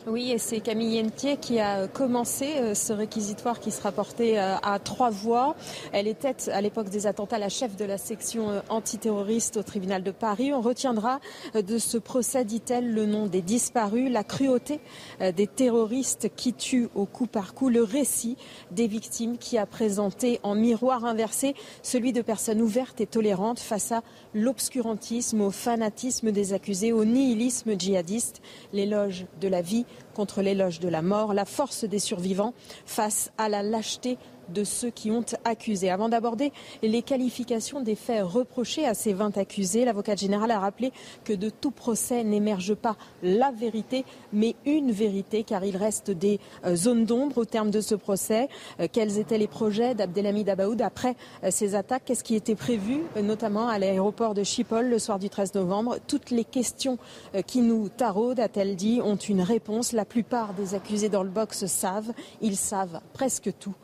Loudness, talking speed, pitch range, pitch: -27 LUFS, 170 wpm, 205-240 Hz, 220 Hz